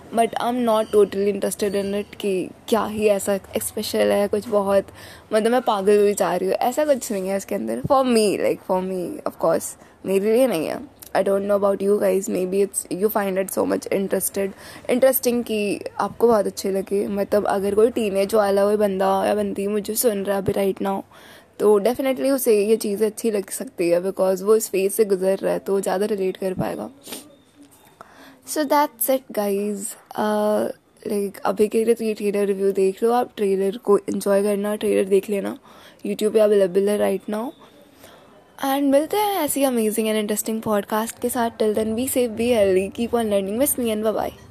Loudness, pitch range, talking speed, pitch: -21 LUFS, 195-230 Hz, 210 wpm, 210 Hz